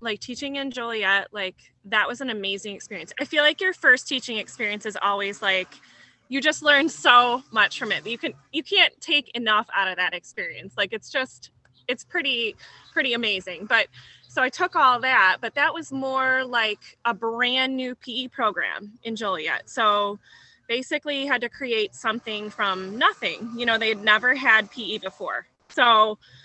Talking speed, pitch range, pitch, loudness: 180 wpm, 210-265 Hz, 235 Hz, -23 LUFS